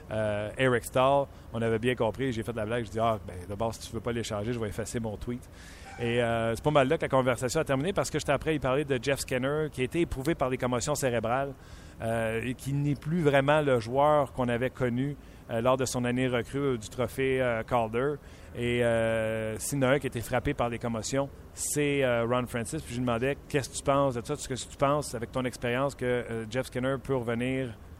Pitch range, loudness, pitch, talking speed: 115-135 Hz, -29 LUFS, 125 Hz, 250 wpm